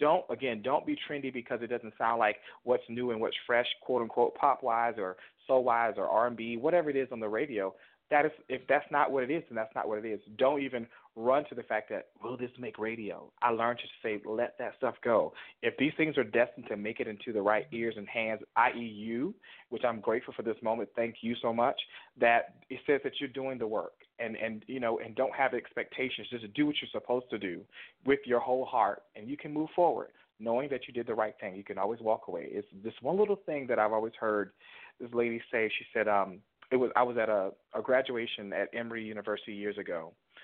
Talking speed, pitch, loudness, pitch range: 240 wpm, 120 Hz, -32 LUFS, 110-130 Hz